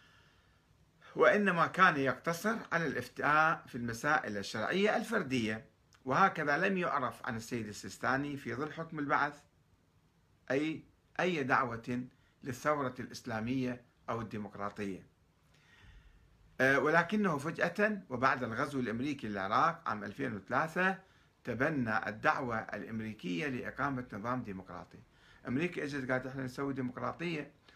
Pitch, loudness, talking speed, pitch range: 130 Hz, -34 LUFS, 100 wpm, 110-150 Hz